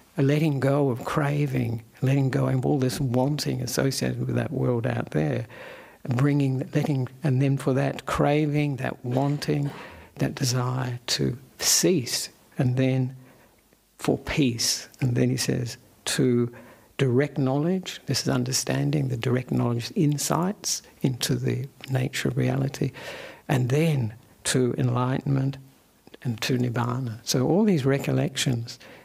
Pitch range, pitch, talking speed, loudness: 125-140 Hz, 130 Hz, 130 wpm, -25 LUFS